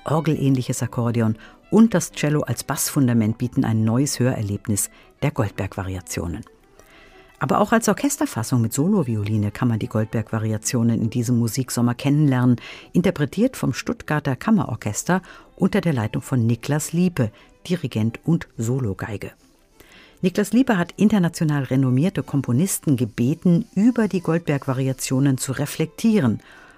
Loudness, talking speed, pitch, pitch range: -21 LUFS, 115 wpm, 135 Hz, 115-175 Hz